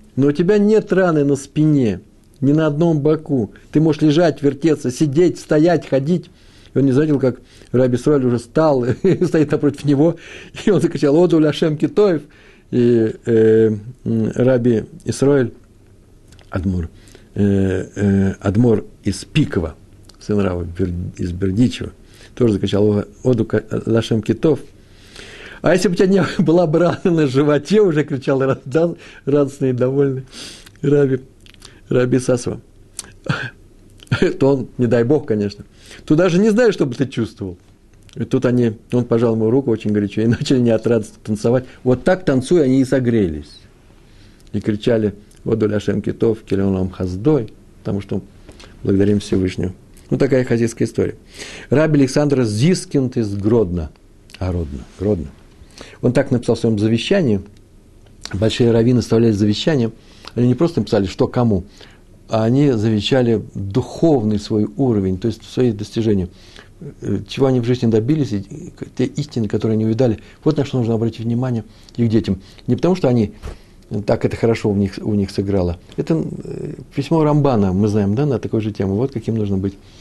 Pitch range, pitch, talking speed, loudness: 100-140 Hz, 115 Hz, 150 wpm, -17 LUFS